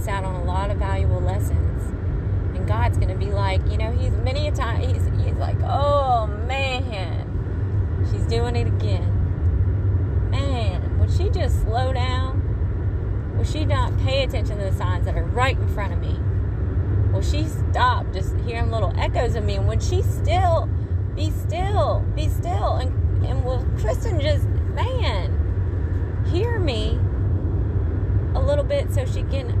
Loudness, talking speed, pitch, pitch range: -22 LUFS, 160 wpm, 95 Hz, 95-100 Hz